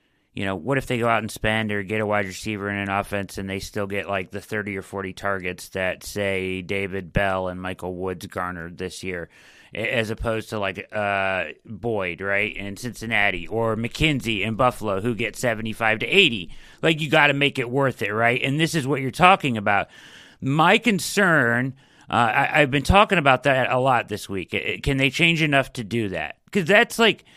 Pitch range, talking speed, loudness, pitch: 100-135 Hz, 205 wpm, -22 LUFS, 110 Hz